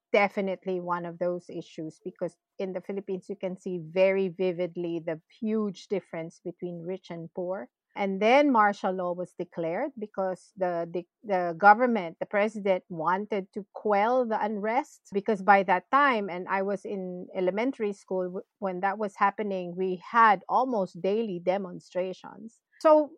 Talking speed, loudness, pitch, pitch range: 155 wpm, -28 LUFS, 190 Hz, 180-210 Hz